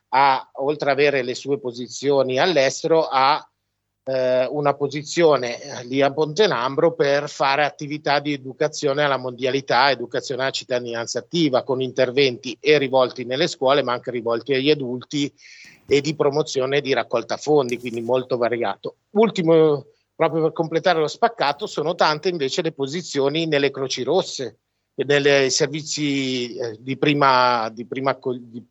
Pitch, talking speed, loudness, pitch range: 140 Hz, 145 wpm, -21 LUFS, 130-150 Hz